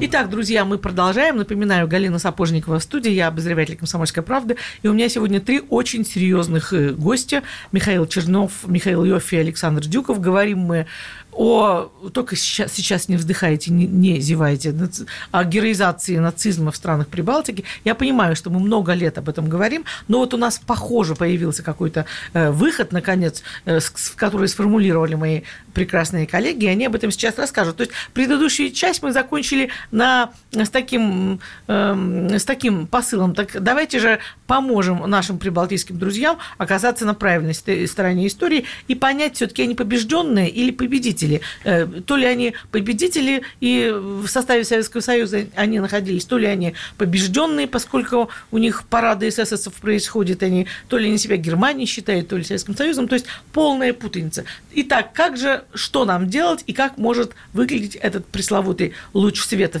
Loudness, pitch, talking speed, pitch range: -19 LUFS, 205 Hz, 155 wpm, 180-245 Hz